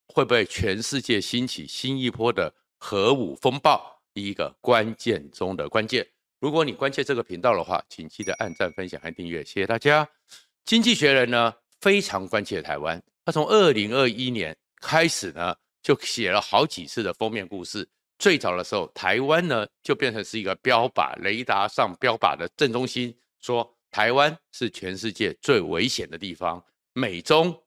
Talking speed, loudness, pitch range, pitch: 260 characters per minute, -24 LUFS, 115-150 Hz, 125 Hz